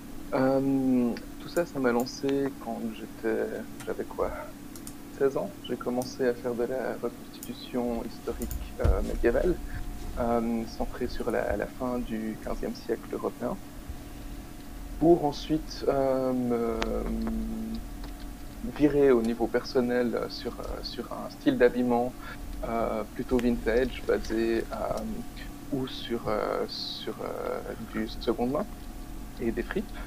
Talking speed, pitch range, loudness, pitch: 120 wpm, 115-130 Hz, -30 LUFS, 125 Hz